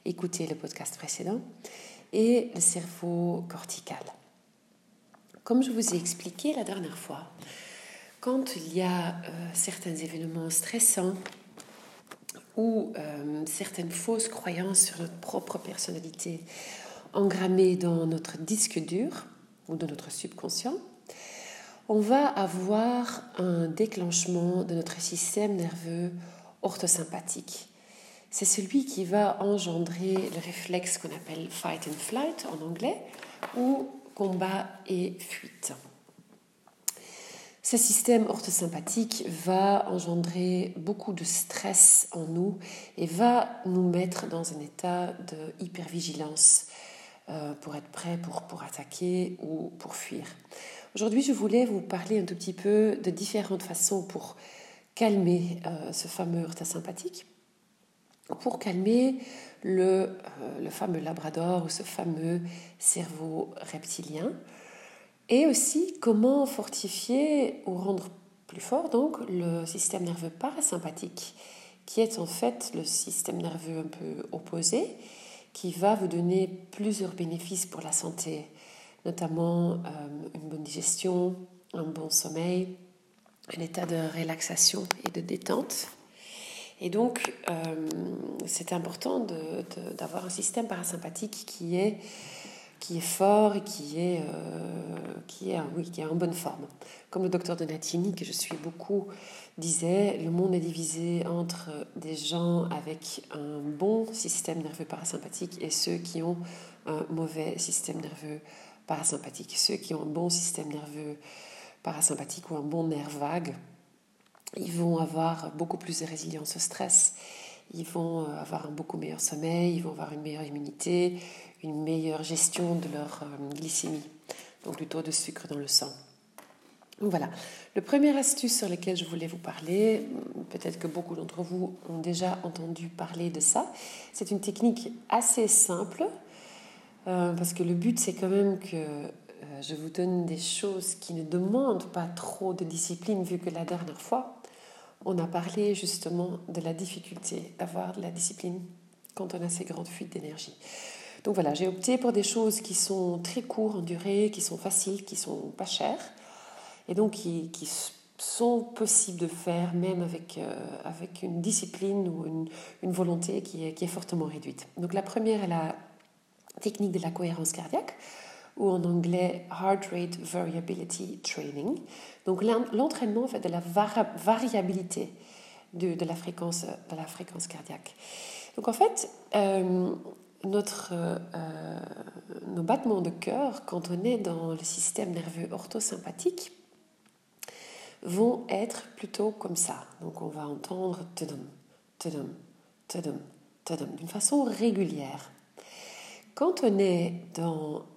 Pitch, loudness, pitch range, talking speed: 180 Hz, -30 LUFS, 165-200 Hz, 140 wpm